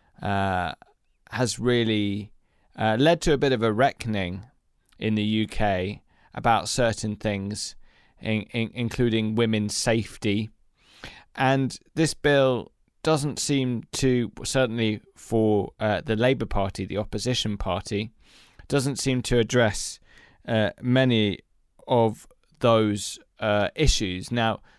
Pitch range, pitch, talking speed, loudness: 105-125 Hz, 110 Hz, 115 wpm, -25 LUFS